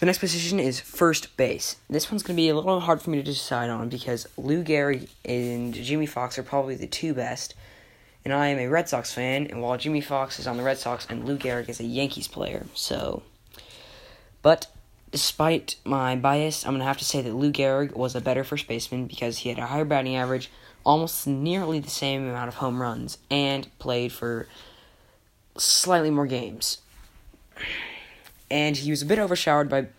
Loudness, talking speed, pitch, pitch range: -26 LUFS, 200 wpm, 135 Hz, 125-150 Hz